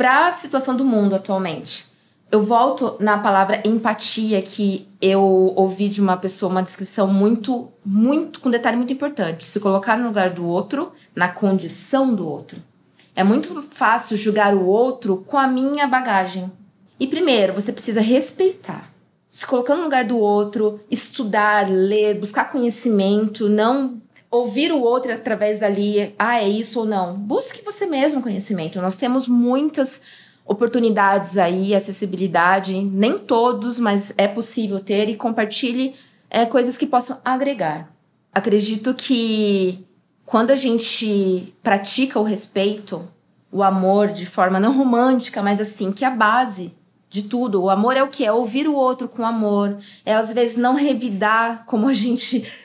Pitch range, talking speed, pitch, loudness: 195-250 Hz, 155 wpm, 215 Hz, -19 LUFS